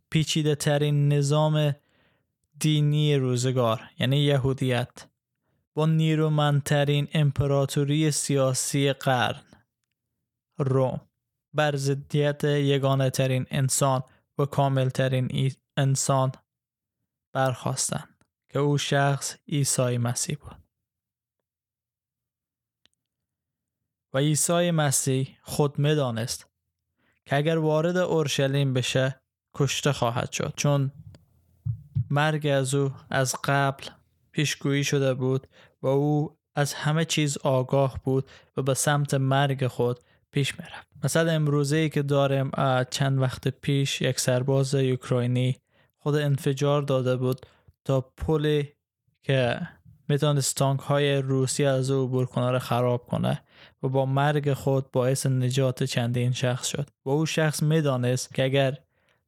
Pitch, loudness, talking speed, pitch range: 135 Hz, -25 LUFS, 110 wpm, 130-145 Hz